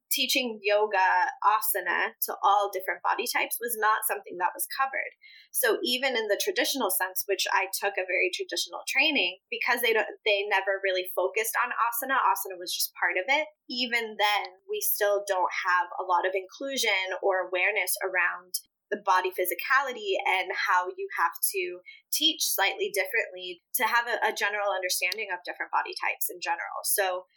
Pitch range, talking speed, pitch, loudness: 185-265 Hz, 175 wpm, 205 Hz, -27 LUFS